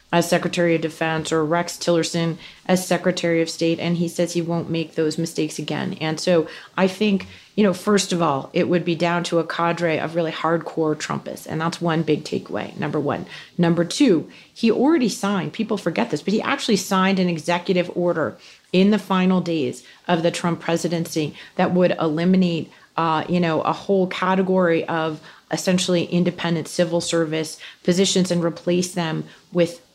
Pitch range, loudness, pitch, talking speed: 165-185 Hz, -21 LUFS, 170 Hz, 180 wpm